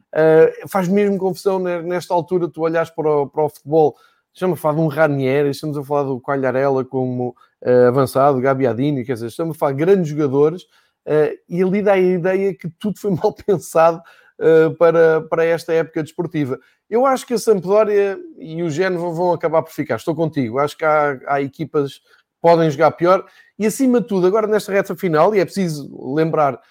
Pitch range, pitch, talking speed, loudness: 145-185 Hz, 165 Hz, 190 wpm, -18 LUFS